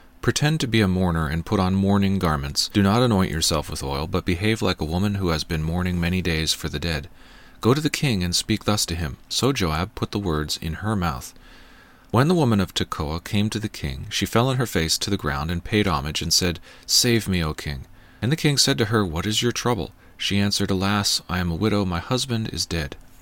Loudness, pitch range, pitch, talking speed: -22 LUFS, 85-110 Hz, 95 Hz, 245 wpm